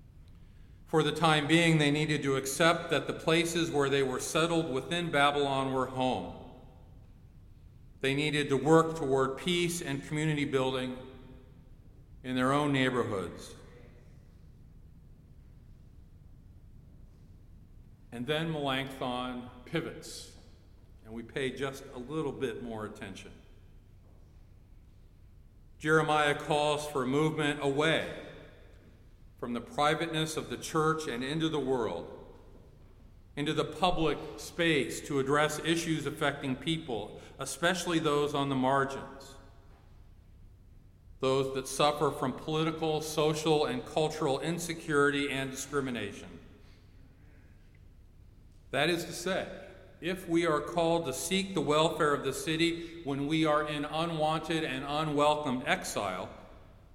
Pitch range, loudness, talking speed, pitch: 105-155 Hz, -31 LUFS, 115 wpm, 135 Hz